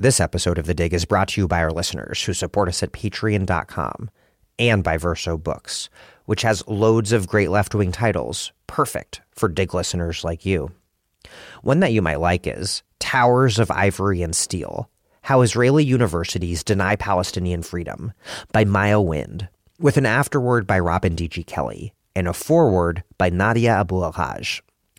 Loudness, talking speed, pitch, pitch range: -21 LUFS, 165 wpm, 95 Hz, 85-110 Hz